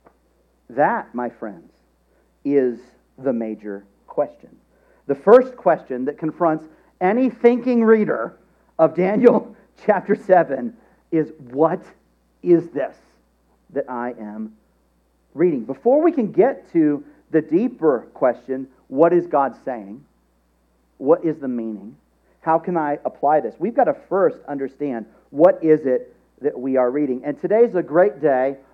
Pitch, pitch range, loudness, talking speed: 145 Hz, 110-180 Hz, -20 LUFS, 135 wpm